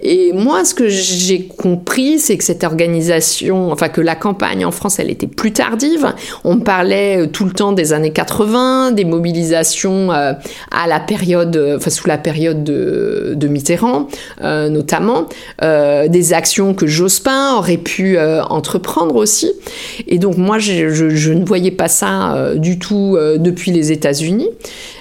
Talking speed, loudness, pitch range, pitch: 165 wpm, -13 LUFS, 165-215 Hz, 180 Hz